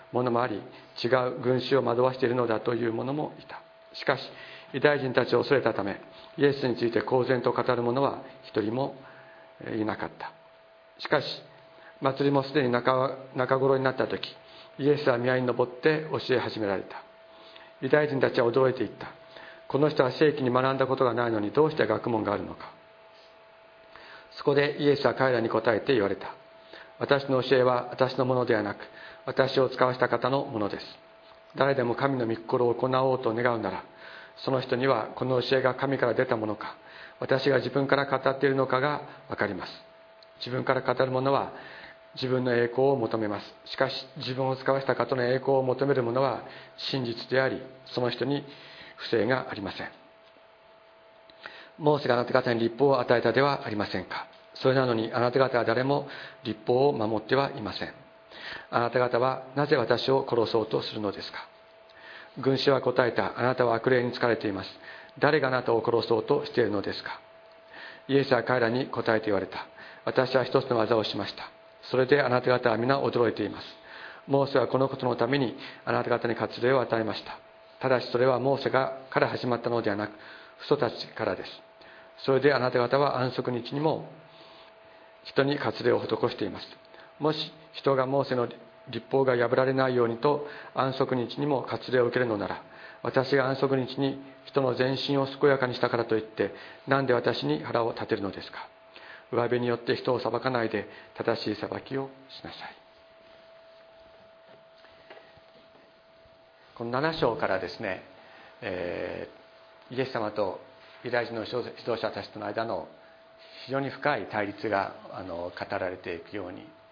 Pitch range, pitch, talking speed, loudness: 120-135 Hz, 130 Hz, 340 characters per minute, -27 LUFS